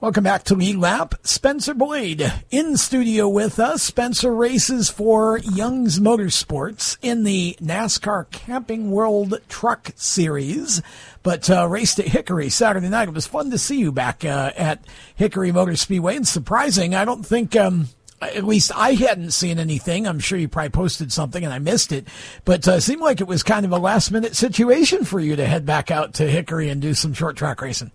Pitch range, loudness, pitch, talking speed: 160-225 Hz, -19 LUFS, 185 Hz, 195 wpm